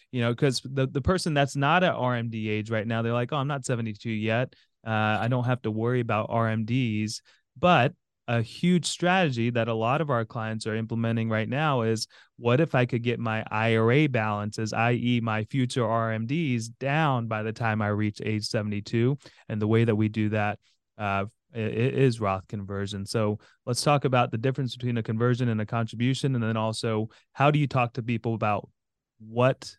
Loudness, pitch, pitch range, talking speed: -27 LUFS, 115 Hz, 110-130 Hz, 200 wpm